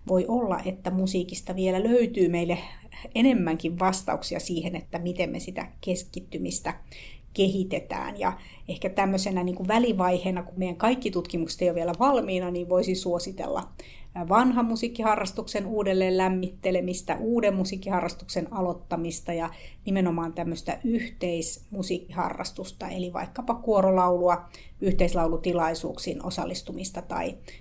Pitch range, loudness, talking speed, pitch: 175-200 Hz, -27 LUFS, 110 wpm, 185 Hz